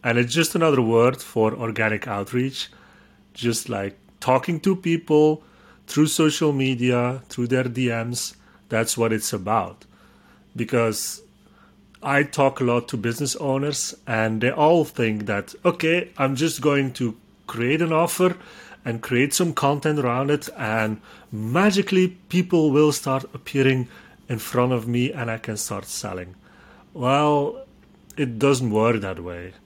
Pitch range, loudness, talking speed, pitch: 115-150 Hz, -22 LUFS, 145 wpm, 130 Hz